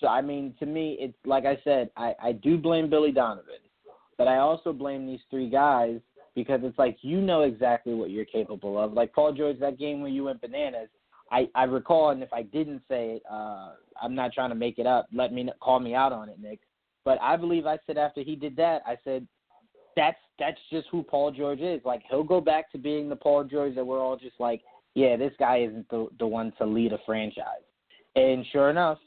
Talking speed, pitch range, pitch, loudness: 230 wpm, 120-150 Hz, 135 Hz, -27 LUFS